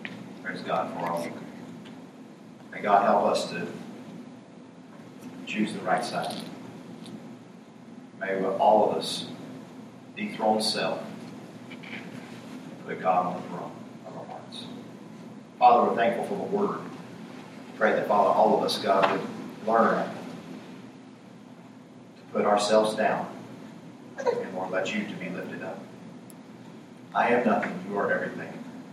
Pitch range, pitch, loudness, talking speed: 95-110 Hz, 105 Hz, -26 LUFS, 125 wpm